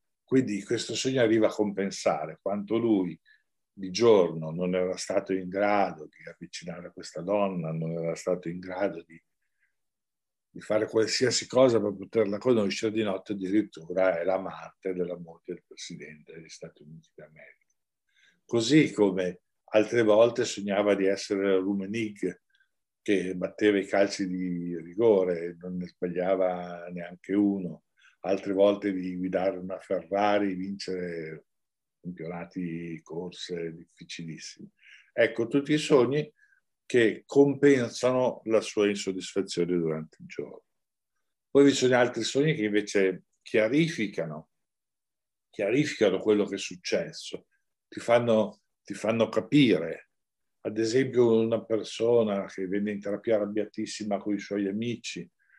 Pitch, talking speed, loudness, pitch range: 100 Hz, 130 wpm, -27 LUFS, 90-110 Hz